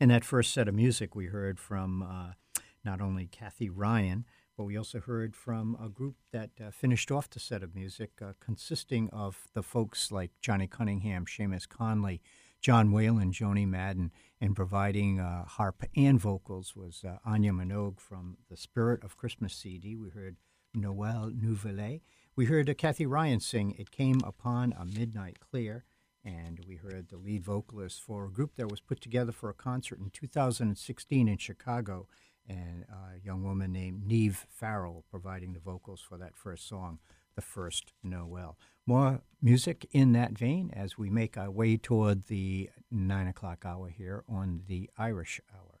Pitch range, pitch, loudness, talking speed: 95-115 Hz, 105 Hz, -33 LUFS, 175 wpm